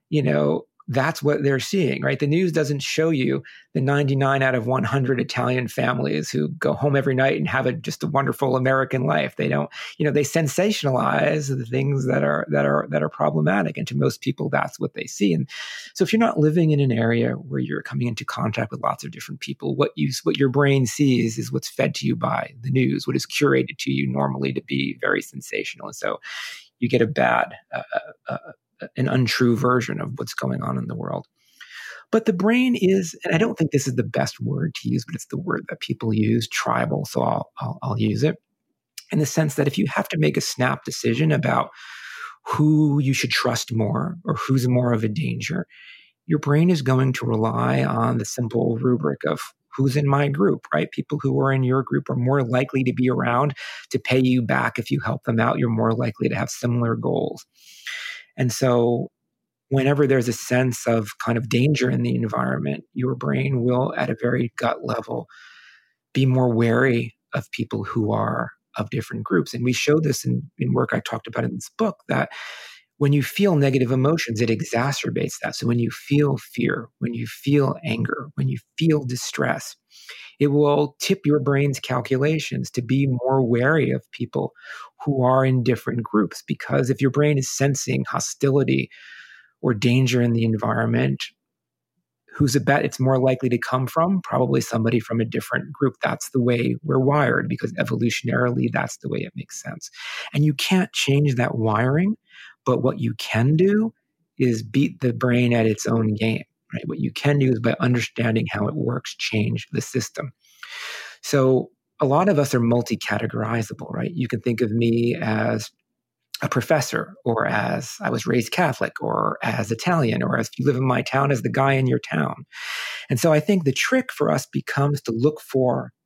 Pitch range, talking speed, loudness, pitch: 115-145 Hz, 200 wpm, -22 LUFS, 130 Hz